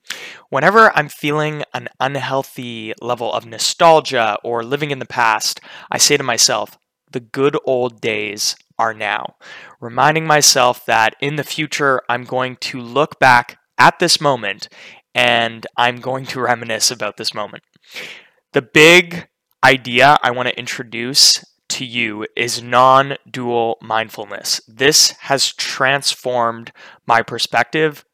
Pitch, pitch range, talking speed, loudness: 125 Hz, 120-140 Hz, 135 wpm, -15 LUFS